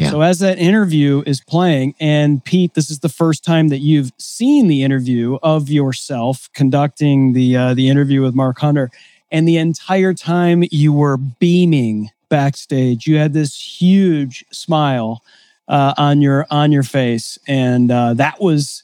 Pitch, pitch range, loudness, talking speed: 145 Hz, 135-160 Hz, -15 LUFS, 160 wpm